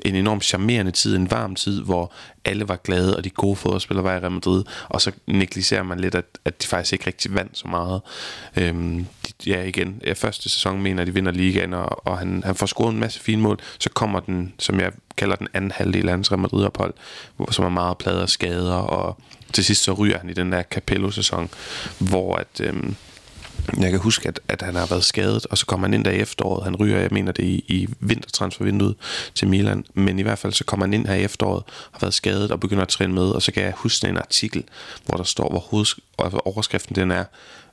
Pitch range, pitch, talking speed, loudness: 90-105 Hz, 95 Hz, 235 wpm, -22 LUFS